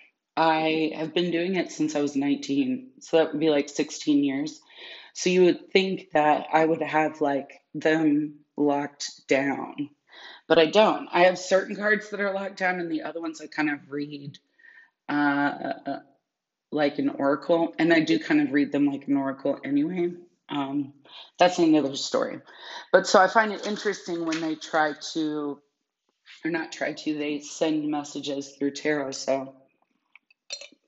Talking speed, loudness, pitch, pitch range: 165 wpm, -25 LUFS, 160 Hz, 145-195 Hz